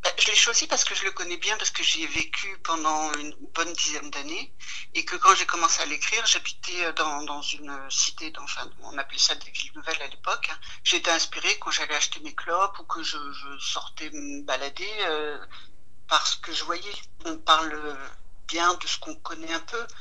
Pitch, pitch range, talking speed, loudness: 155 Hz, 140-165 Hz, 205 wpm, -25 LUFS